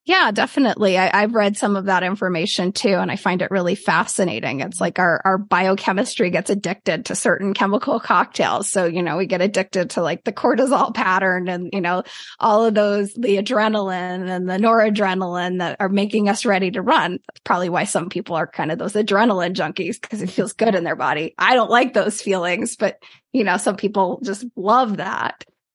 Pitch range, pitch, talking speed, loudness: 185-215 Hz, 195 Hz, 205 wpm, -19 LUFS